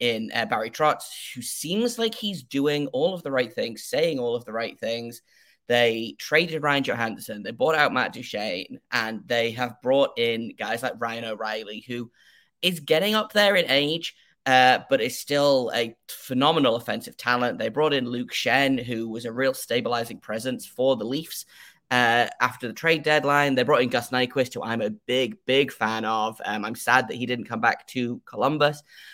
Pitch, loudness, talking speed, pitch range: 125 Hz, -24 LUFS, 195 wpm, 115-145 Hz